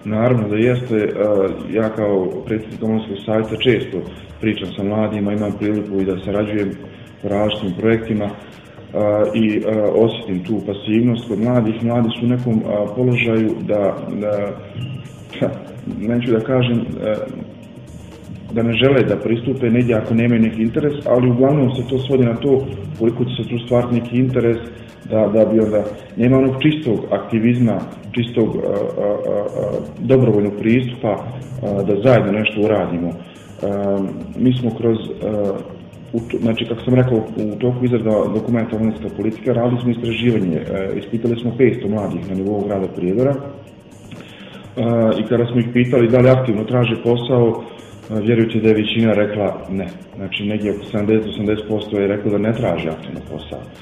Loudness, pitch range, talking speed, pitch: -18 LUFS, 105-120 Hz, 150 wpm, 110 Hz